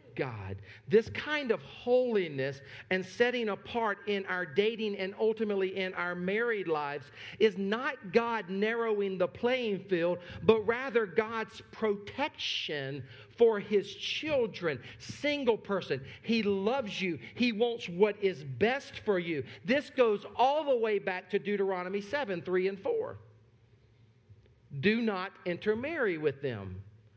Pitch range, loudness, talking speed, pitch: 170-225 Hz, -31 LUFS, 135 wpm, 200 Hz